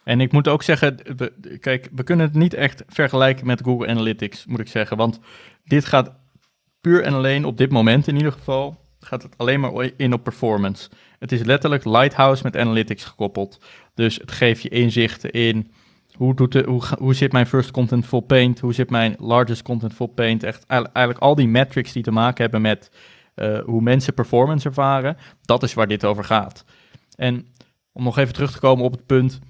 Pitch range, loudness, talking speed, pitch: 115-135 Hz, -19 LUFS, 205 wpm, 125 Hz